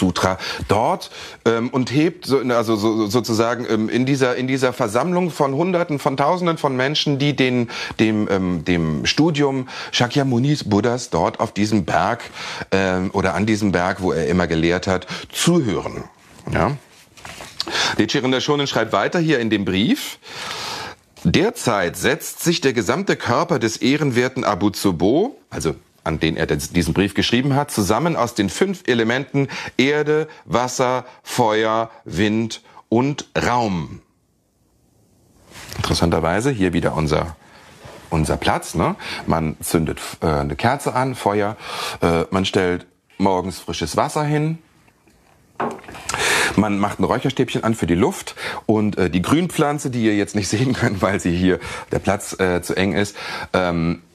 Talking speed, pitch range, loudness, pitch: 145 wpm, 95-135 Hz, -20 LUFS, 110 Hz